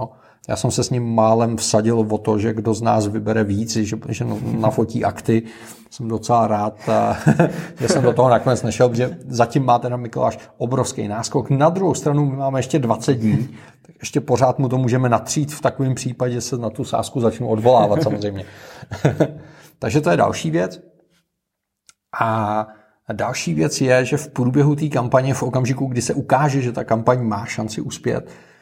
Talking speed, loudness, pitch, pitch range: 180 wpm, -19 LUFS, 120 Hz, 110-135 Hz